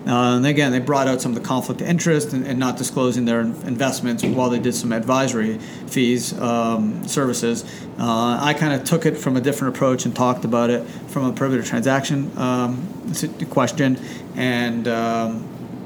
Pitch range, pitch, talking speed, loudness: 120-135 Hz, 125 Hz, 180 wpm, -20 LUFS